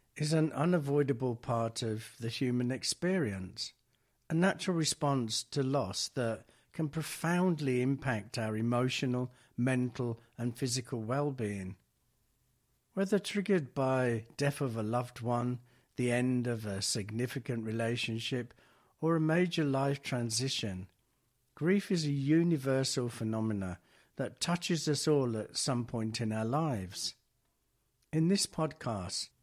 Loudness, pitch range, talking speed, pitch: -33 LUFS, 115-145 Hz, 120 wpm, 125 Hz